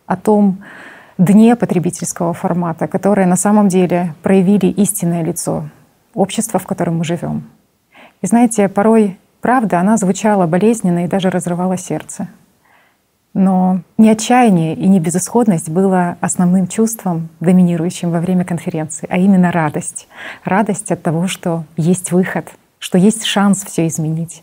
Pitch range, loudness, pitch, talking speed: 175-200 Hz, -14 LUFS, 185 Hz, 135 wpm